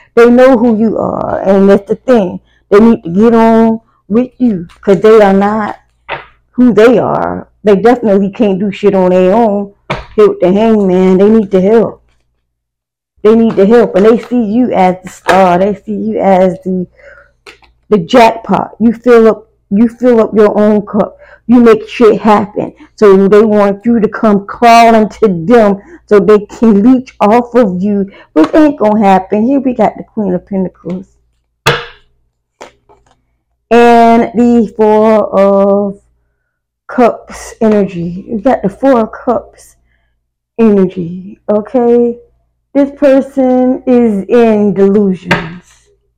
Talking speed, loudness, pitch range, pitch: 150 wpm, -9 LUFS, 195-235 Hz, 210 Hz